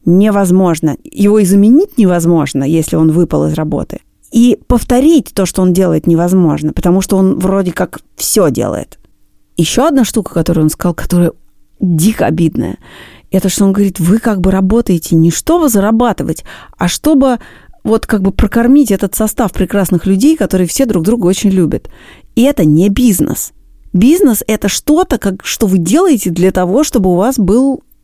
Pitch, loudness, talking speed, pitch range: 195 Hz, -11 LUFS, 165 wpm, 175-235 Hz